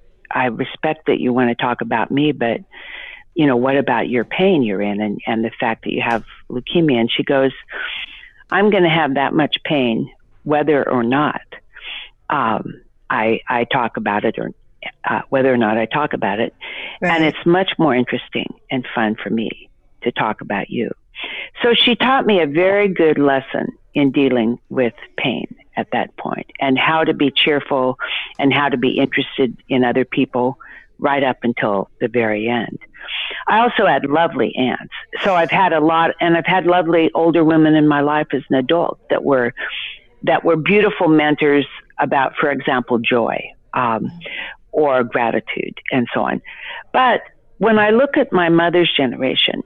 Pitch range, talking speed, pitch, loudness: 125-170 Hz, 180 wpm, 145 Hz, -17 LUFS